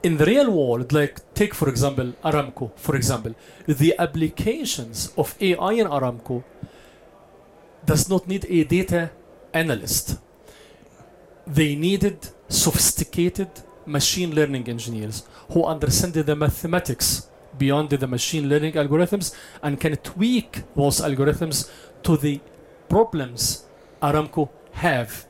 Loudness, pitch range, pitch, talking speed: -22 LUFS, 135-175 Hz, 150 Hz, 115 wpm